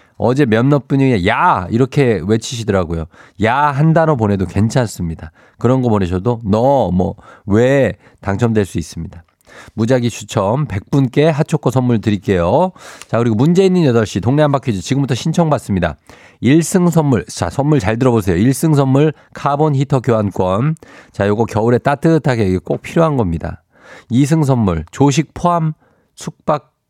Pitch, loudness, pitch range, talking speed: 120 Hz, -15 LUFS, 105-145 Hz, 305 characters per minute